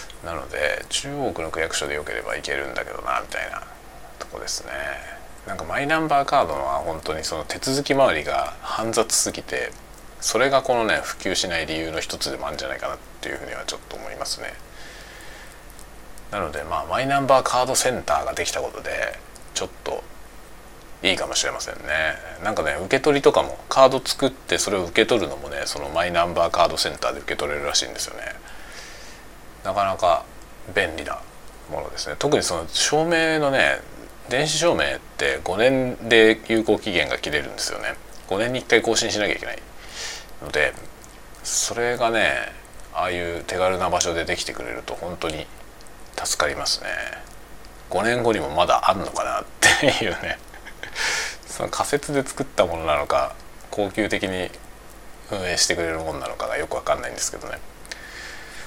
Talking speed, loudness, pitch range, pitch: 355 characters per minute, -23 LUFS, 85-135 Hz, 110 Hz